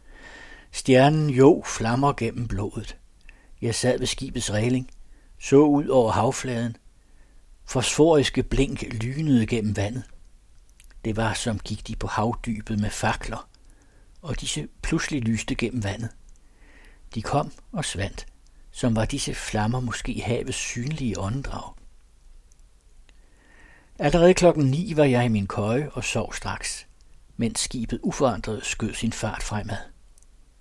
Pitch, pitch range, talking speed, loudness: 115 Hz, 105-130 Hz, 125 wpm, -24 LUFS